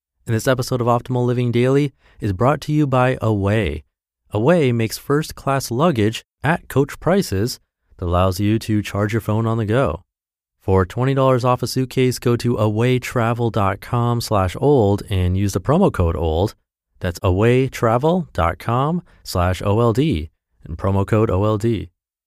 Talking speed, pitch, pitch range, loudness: 140 wpm, 115 Hz, 95-130 Hz, -19 LUFS